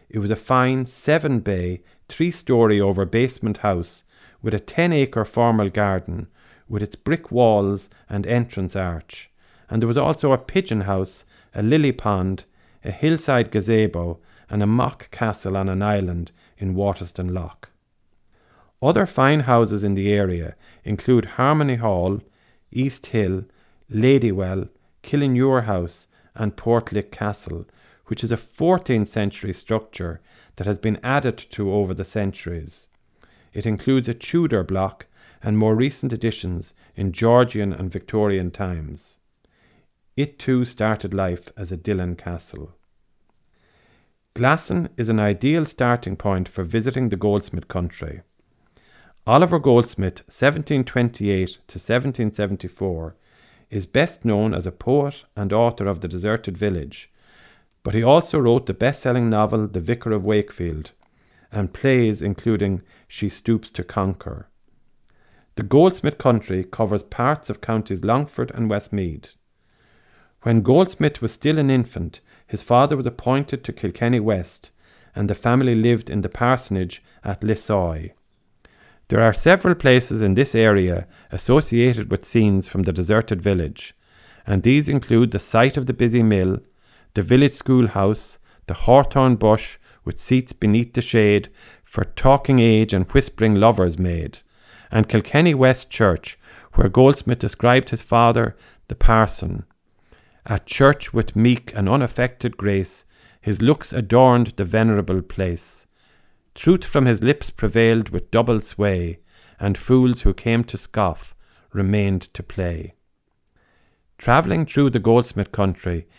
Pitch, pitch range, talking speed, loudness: 110 Hz, 95-125 Hz, 140 wpm, -20 LUFS